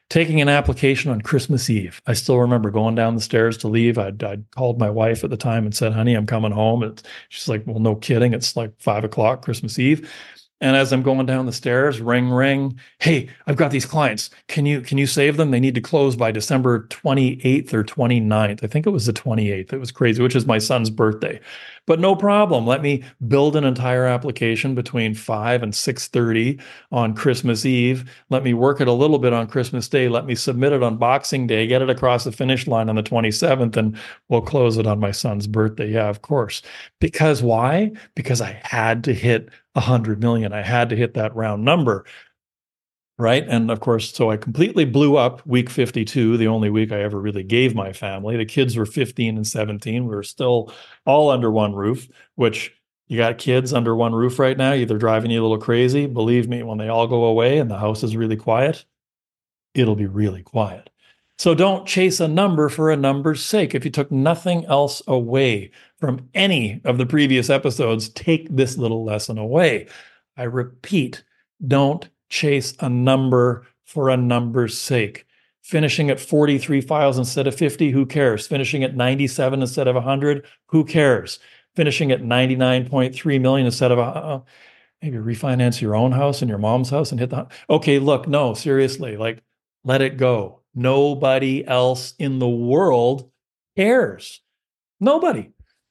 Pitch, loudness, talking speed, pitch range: 125 Hz, -19 LUFS, 195 wpm, 115-140 Hz